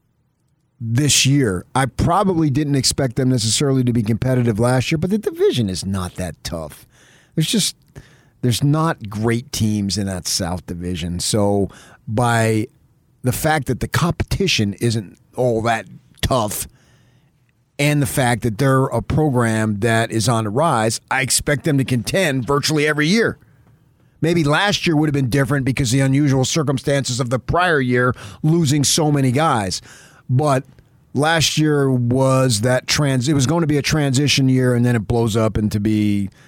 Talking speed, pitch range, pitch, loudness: 165 wpm, 115-145 Hz, 130 Hz, -18 LUFS